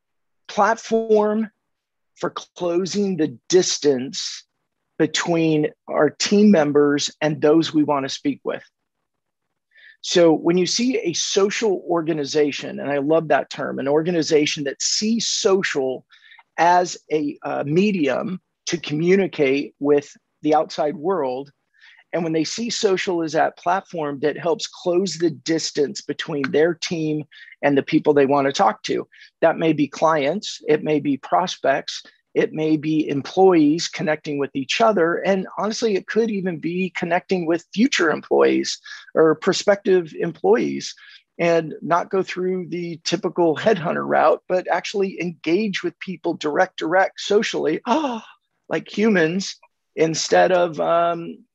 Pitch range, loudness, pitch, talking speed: 150-195 Hz, -20 LUFS, 170 Hz, 135 wpm